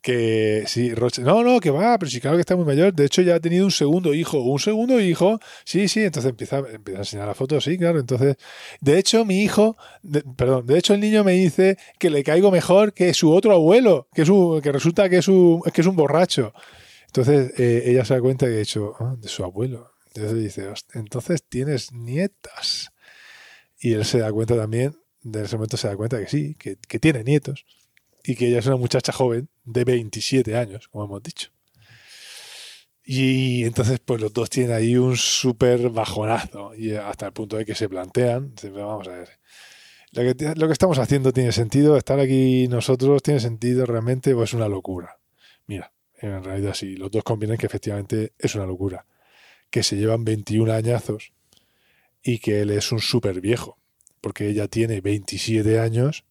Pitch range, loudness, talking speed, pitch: 110-150 Hz, -20 LUFS, 200 wpm, 125 Hz